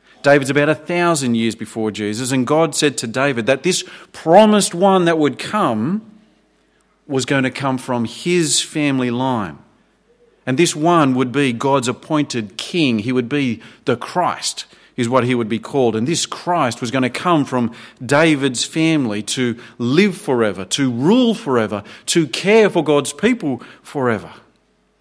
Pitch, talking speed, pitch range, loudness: 140 Hz, 165 wpm, 120-170 Hz, -17 LUFS